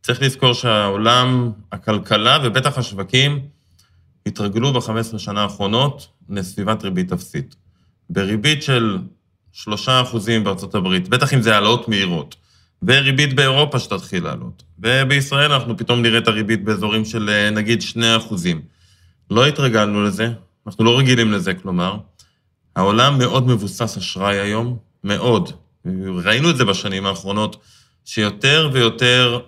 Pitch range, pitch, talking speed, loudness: 100-125 Hz, 110 Hz, 120 wpm, -17 LUFS